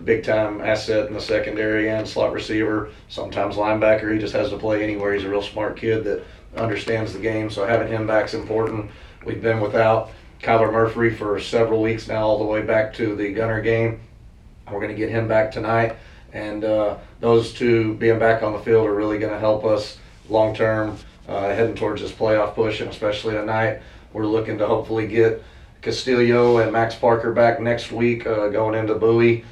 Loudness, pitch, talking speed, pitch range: -21 LUFS, 110 Hz, 200 wpm, 105-115 Hz